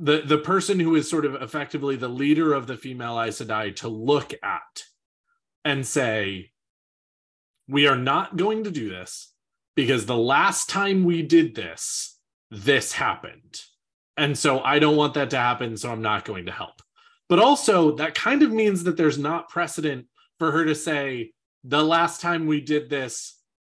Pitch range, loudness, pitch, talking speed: 130-170 Hz, -23 LUFS, 150 Hz, 175 wpm